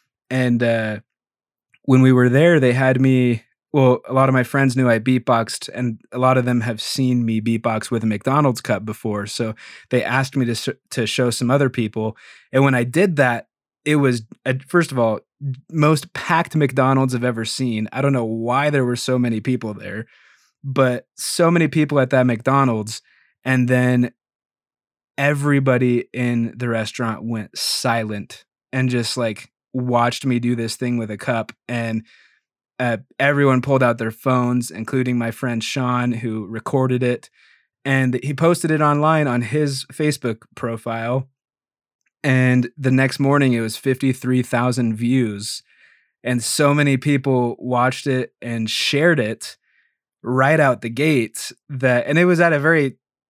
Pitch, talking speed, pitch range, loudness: 125 Hz, 165 wpm, 115-135 Hz, -19 LUFS